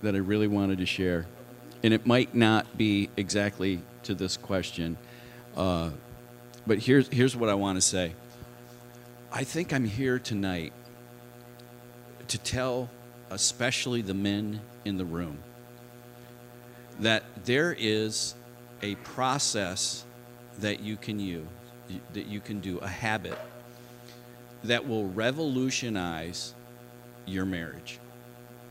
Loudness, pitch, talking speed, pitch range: -29 LUFS, 120 Hz, 120 wpm, 100-120 Hz